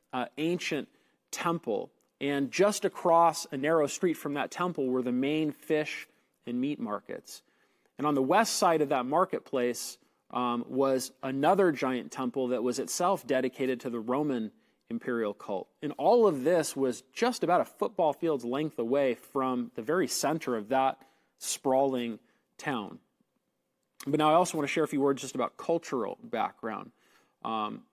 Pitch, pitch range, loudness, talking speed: 140 Hz, 130-160 Hz, -30 LUFS, 165 wpm